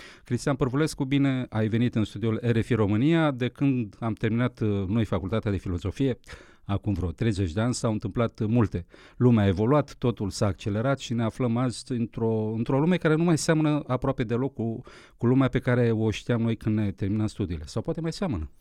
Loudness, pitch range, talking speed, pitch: -26 LUFS, 110-130 Hz, 195 wpm, 115 Hz